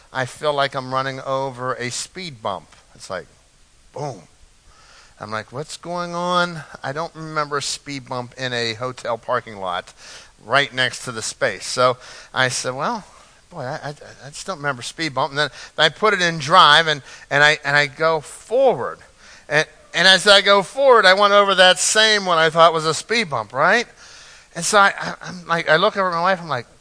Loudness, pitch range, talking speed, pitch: -18 LUFS, 135-180 Hz, 210 wpm, 155 Hz